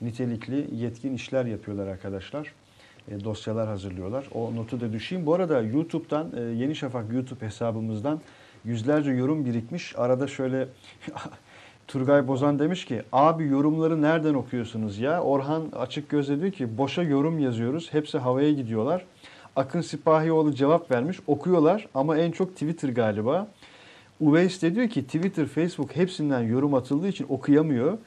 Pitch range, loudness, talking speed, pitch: 120-155 Hz, -26 LUFS, 140 wpm, 140 Hz